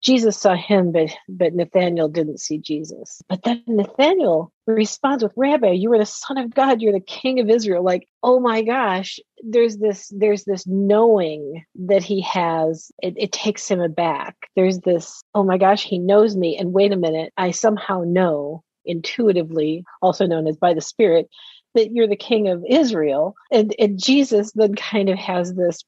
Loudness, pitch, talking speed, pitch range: -19 LUFS, 195 Hz, 185 wpm, 175-220 Hz